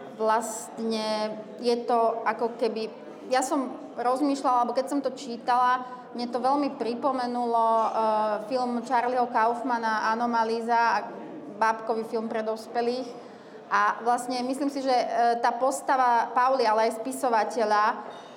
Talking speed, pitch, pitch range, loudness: 125 wpm, 235 Hz, 225-250 Hz, -26 LUFS